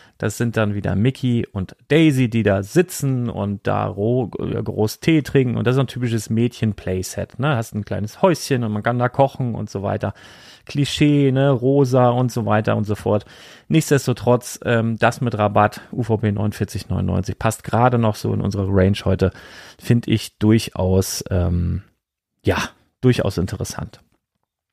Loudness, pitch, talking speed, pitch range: -20 LUFS, 115 Hz, 160 wpm, 100-125 Hz